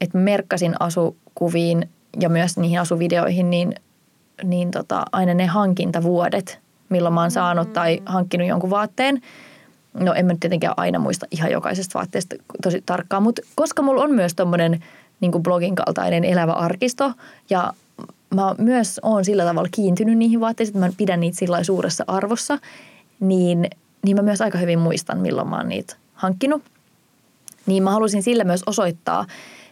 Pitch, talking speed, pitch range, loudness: 185 Hz, 160 wpm, 175-215 Hz, -20 LUFS